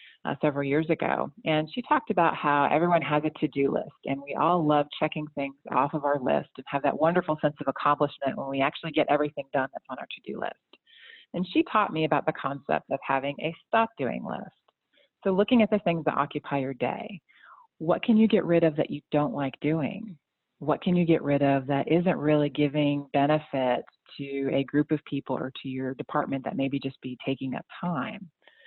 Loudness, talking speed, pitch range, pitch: -27 LUFS, 220 wpm, 140-165 Hz, 150 Hz